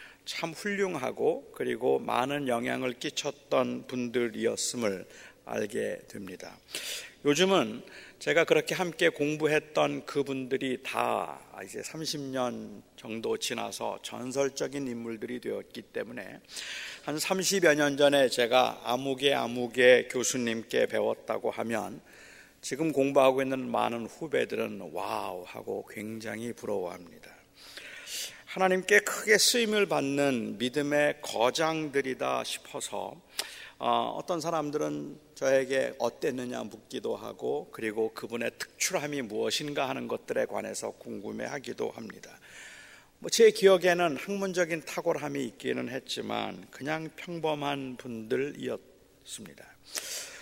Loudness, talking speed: -30 LUFS, 260 characters per minute